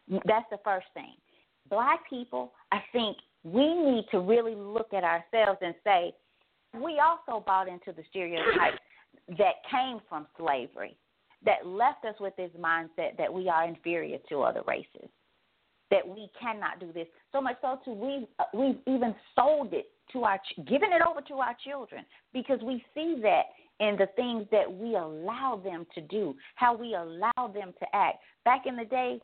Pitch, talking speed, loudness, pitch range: 225 Hz, 175 wpm, -30 LUFS, 190-260 Hz